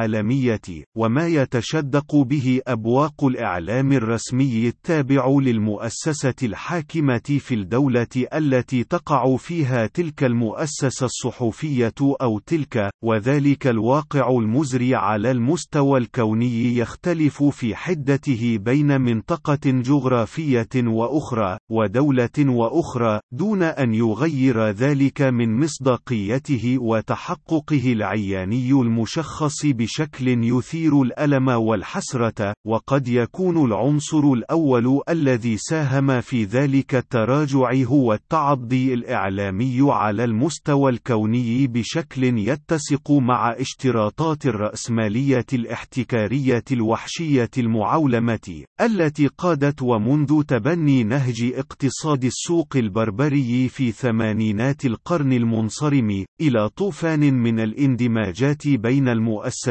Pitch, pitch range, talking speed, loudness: 130 Hz, 115-145 Hz, 90 wpm, -20 LUFS